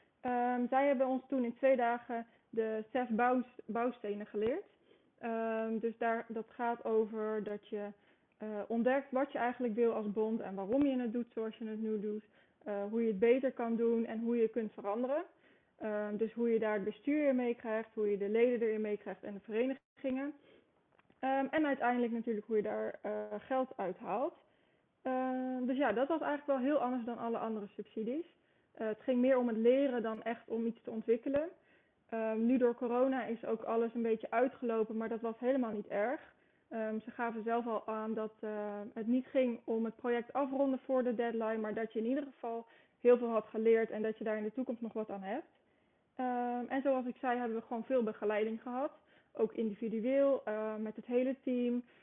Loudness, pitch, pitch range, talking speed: -36 LUFS, 230 Hz, 220-255 Hz, 210 wpm